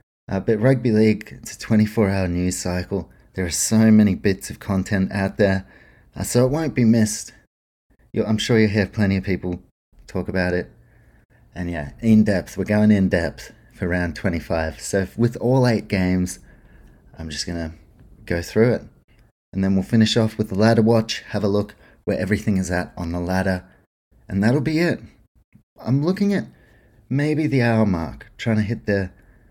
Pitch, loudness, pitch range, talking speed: 100 Hz, -21 LUFS, 90-110 Hz, 190 wpm